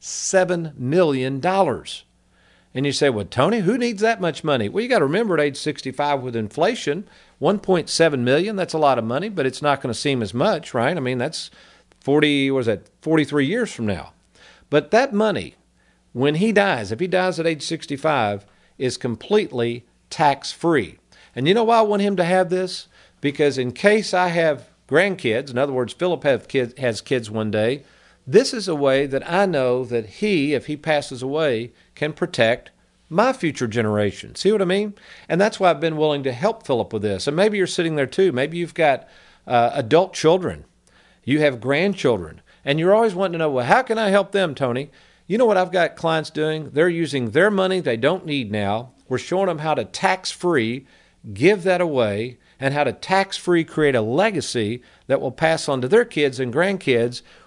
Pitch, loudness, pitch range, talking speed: 150 Hz, -20 LUFS, 130-185 Hz, 205 wpm